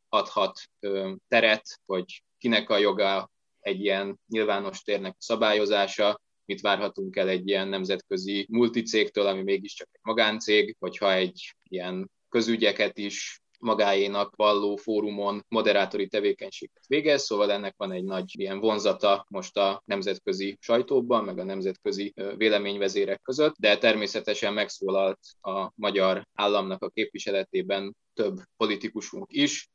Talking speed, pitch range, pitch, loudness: 125 wpm, 95-110 Hz, 100 Hz, -27 LUFS